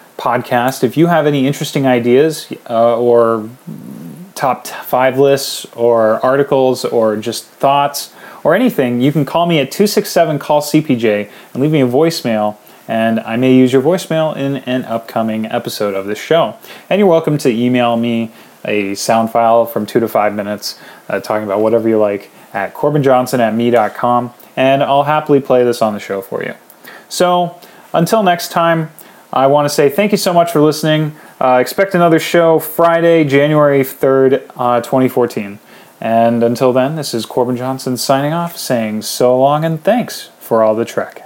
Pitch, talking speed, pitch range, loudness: 130 Hz, 175 wpm, 115-155 Hz, -13 LUFS